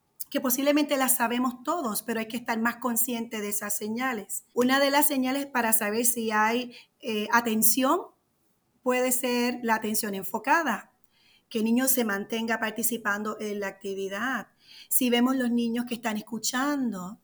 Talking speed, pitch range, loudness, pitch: 155 wpm, 220-255 Hz, -26 LUFS, 235 Hz